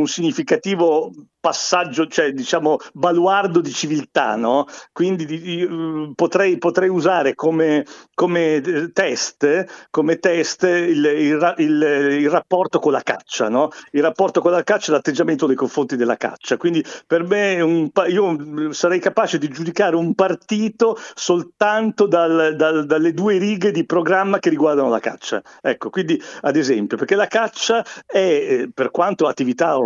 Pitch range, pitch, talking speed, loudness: 155-190 Hz, 170 Hz, 150 wpm, -18 LUFS